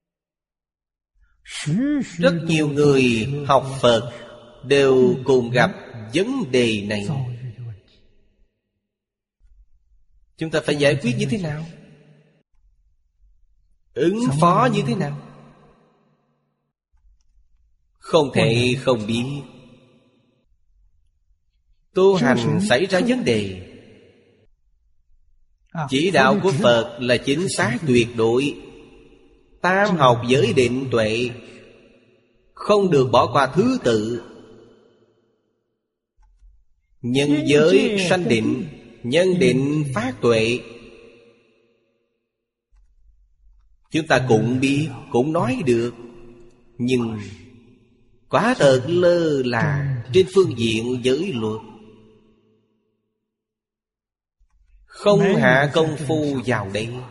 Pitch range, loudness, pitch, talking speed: 105-140 Hz, -19 LUFS, 120 Hz, 90 wpm